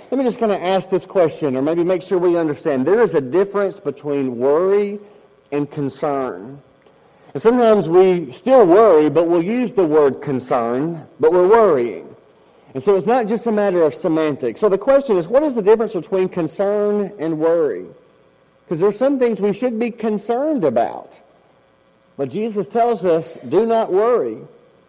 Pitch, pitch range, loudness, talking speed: 190 Hz, 150-225 Hz, -17 LUFS, 175 wpm